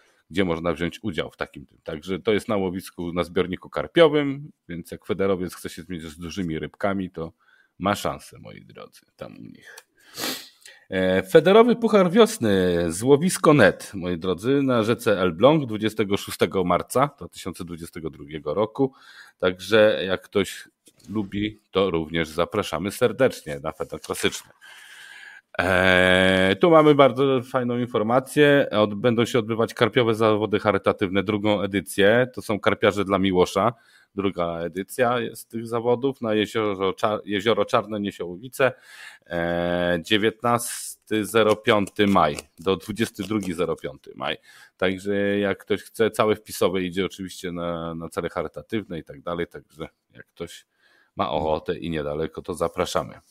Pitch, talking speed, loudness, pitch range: 100 Hz, 135 wpm, -22 LUFS, 90-115 Hz